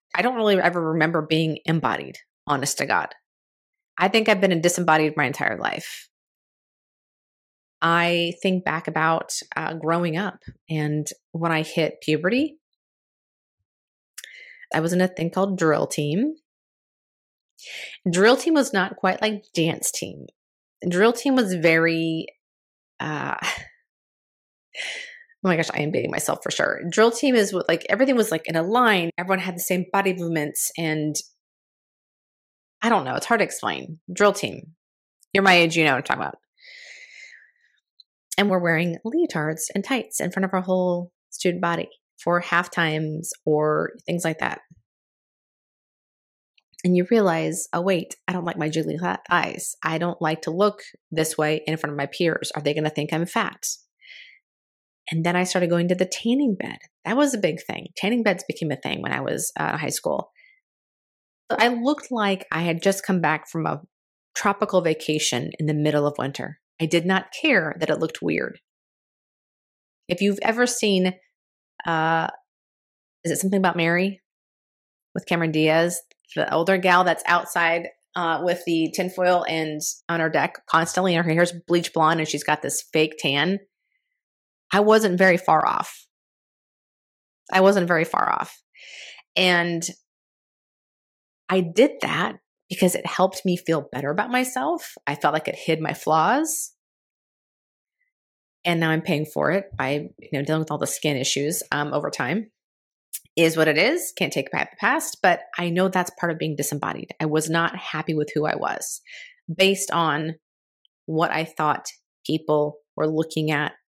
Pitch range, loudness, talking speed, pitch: 160-195 Hz, -23 LUFS, 170 wpm, 175 Hz